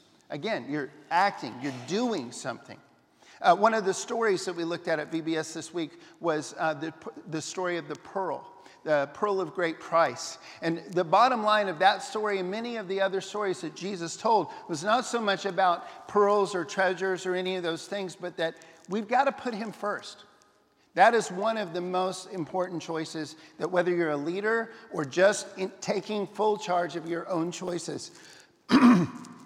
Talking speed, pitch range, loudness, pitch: 185 wpm, 165-205 Hz, -28 LUFS, 185 Hz